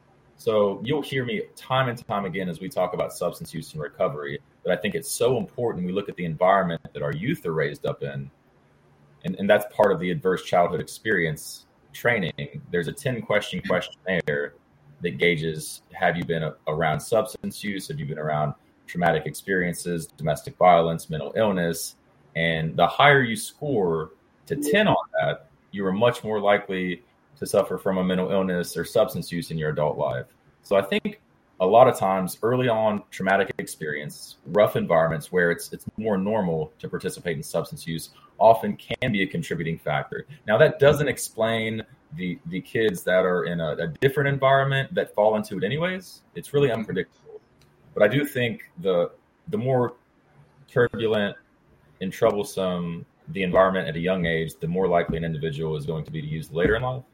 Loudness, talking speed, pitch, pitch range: -24 LUFS, 185 wpm, 95 Hz, 85-130 Hz